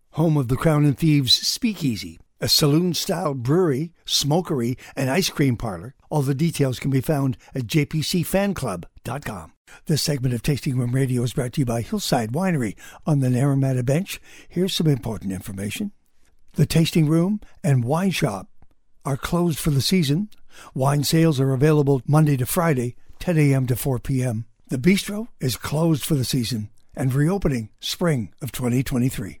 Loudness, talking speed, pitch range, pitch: -22 LUFS, 160 wpm, 125-160 Hz, 140 Hz